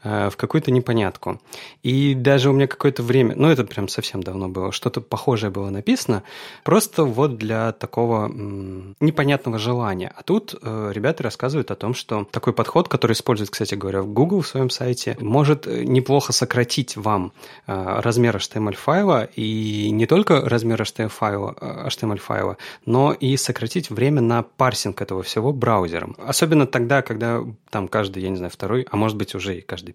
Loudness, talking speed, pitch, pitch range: -21 LUFS, 165 wpm, 115 Hz, 105-135 Hz